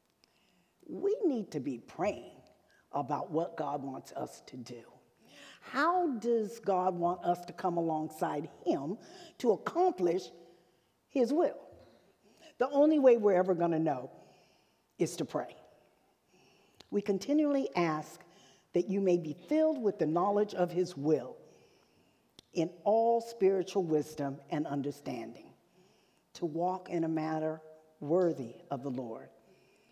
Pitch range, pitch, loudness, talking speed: 155-210 Hz, 175 Hz, -32 LUFS, 130 wpm